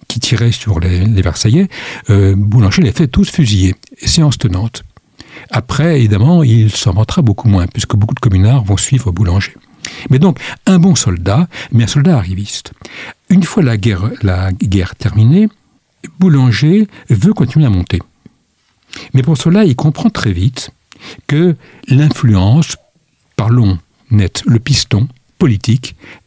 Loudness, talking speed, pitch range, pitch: -12 LUFS, 140 wpm, 105-150 Hz, 120 Hz